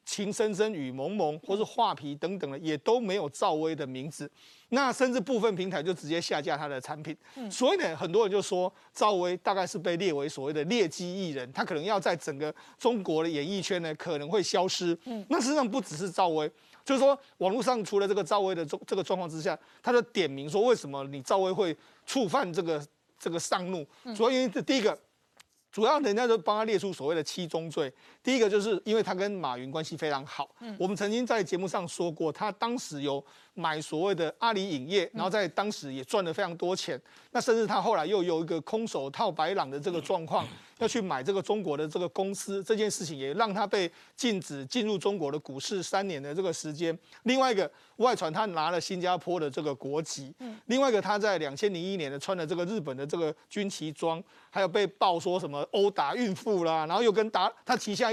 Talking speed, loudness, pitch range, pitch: 330 characters per minute, -30 LUFS, 160-220 Hz, 190 Hz